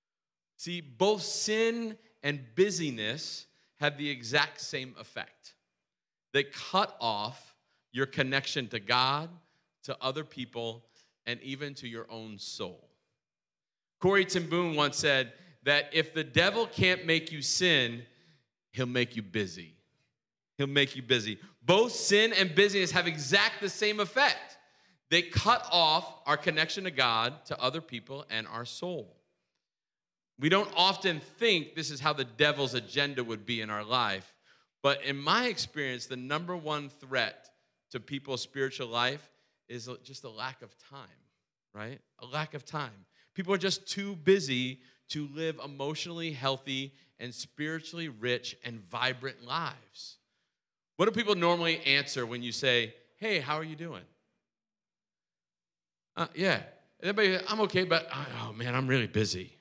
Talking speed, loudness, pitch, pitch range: 145 wpm, -30 LUFS, 145 Hz, 125-170 Hz